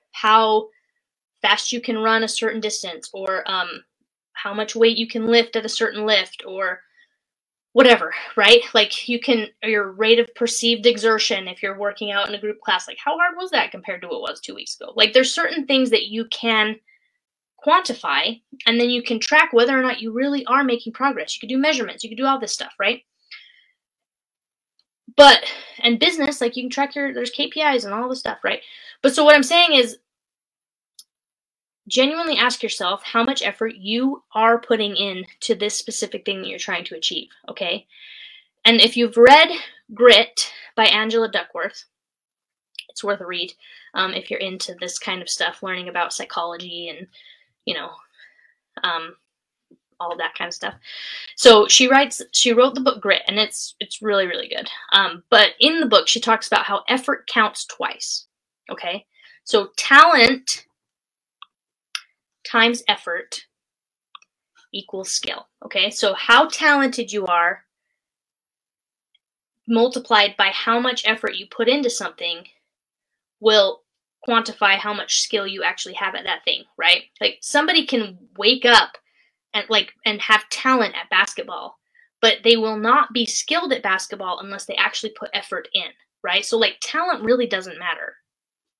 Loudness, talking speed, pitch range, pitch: -18 LUFS, 170 wpm, 210-270 Hz, 230 Hz